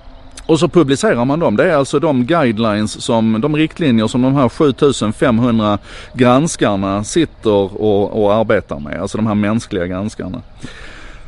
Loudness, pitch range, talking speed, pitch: -15 LUFS, 105-140 Hz, 150 wpm, 115 Hz